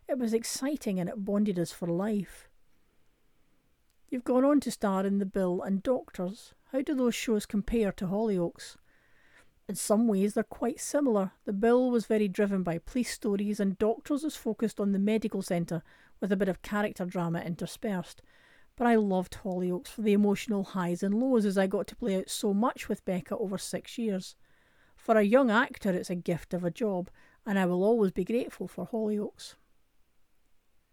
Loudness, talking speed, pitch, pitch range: -30 LUFS, 185 wpm, 205 Hz, 190-230 Hz